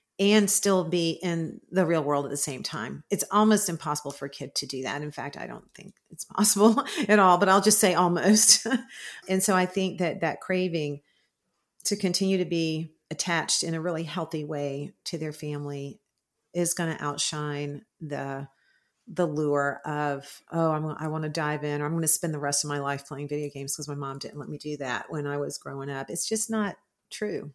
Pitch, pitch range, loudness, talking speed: 160 Hz, 145-185 Hz, -26 LUFS, 215 wpm